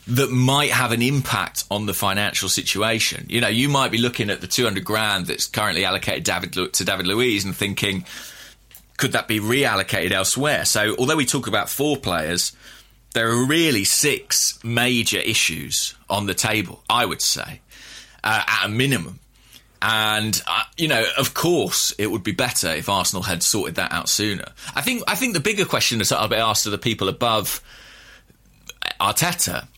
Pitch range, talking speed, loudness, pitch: 100-125 Hz, 185 wpm, -20 LUFS, 110 Hz